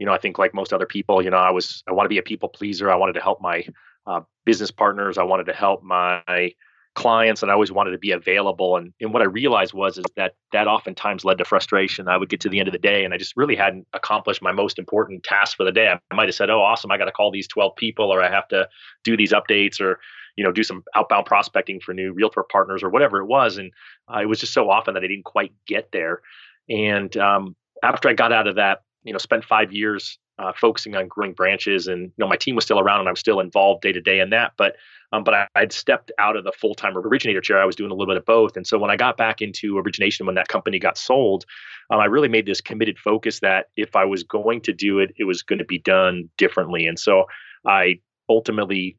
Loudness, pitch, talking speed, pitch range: -20 LUFS, 100 Hz, 265 wpm, 95-105 Hz